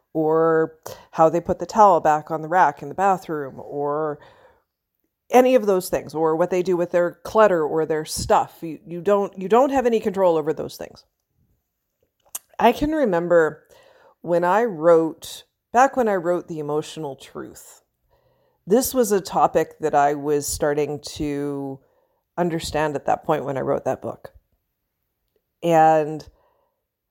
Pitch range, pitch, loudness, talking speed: 155-210 Hz, 170 Hz, -20 LUFS, 155 wpm